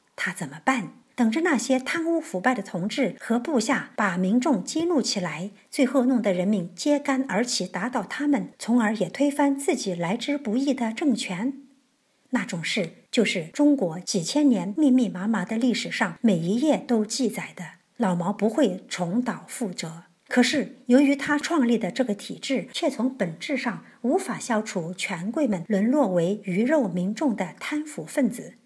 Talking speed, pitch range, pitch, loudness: 255 characters per minute, 195-275 Hz, 235 Hz, -25 LUFS